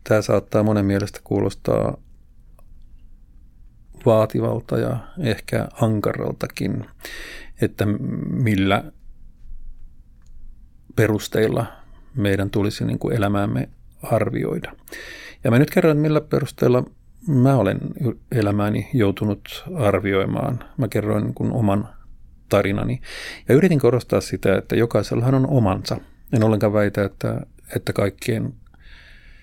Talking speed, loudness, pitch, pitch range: 100 wpm, -21 LUFS, 110 Hz, 100-130 Hz